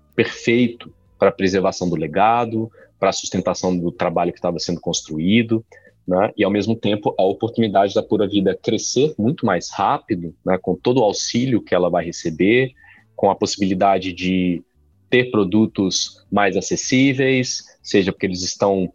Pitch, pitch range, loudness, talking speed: 100 Hz, 90-110 Hz, -19 LUFS, 160 wpm